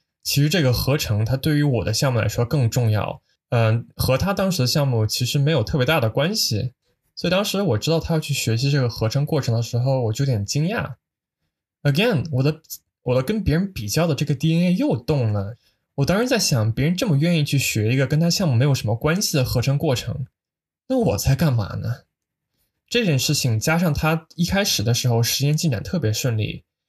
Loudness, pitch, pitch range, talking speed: -21 LUFS, 140 Hz, 120-160 Hz, 320 characters per minute